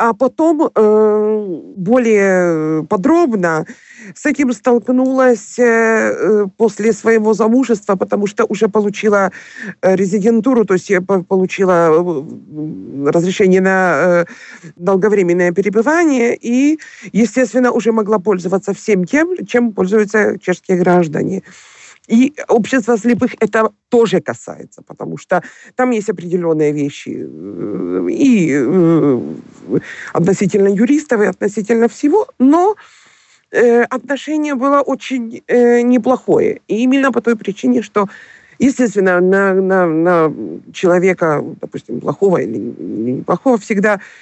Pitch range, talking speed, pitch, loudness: 190-245 Hz, 100 wpm, 215 Hz, -14 LUFS